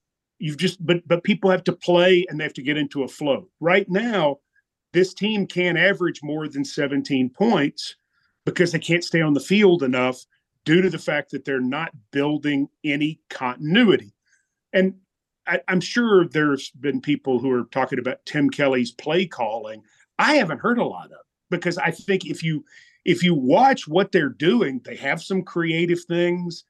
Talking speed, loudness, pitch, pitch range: 180 wpm, -21 LUFS, 170 Hz, 145-185 Hz